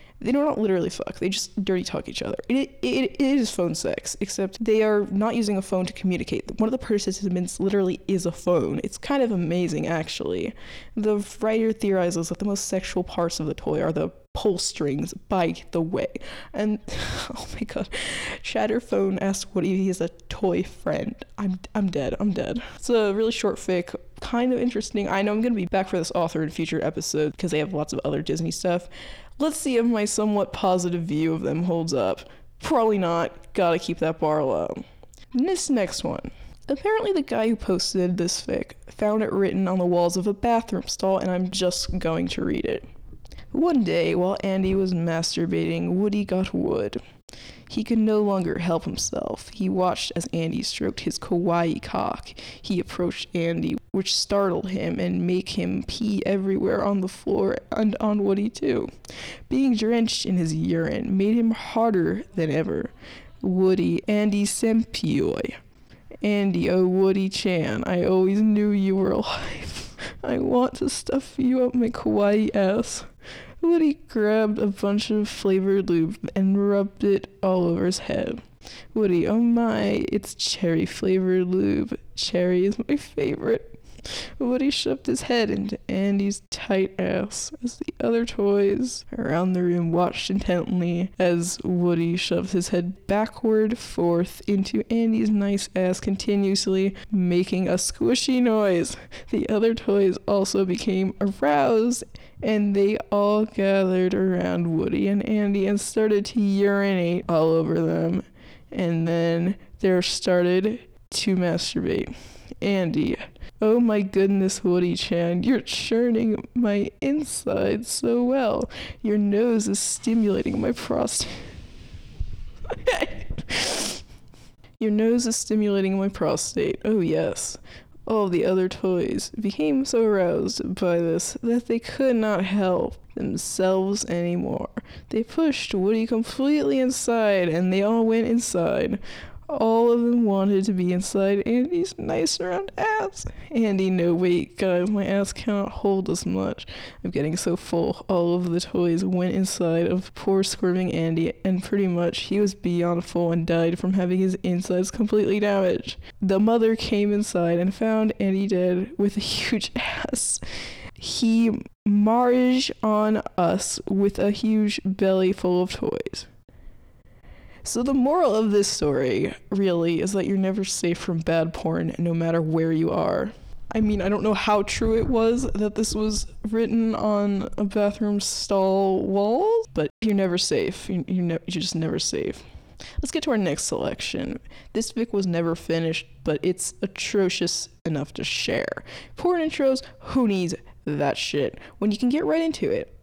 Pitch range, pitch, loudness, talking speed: 180-220 Hz, 200 Hz, -24 LUFS, 160 wpm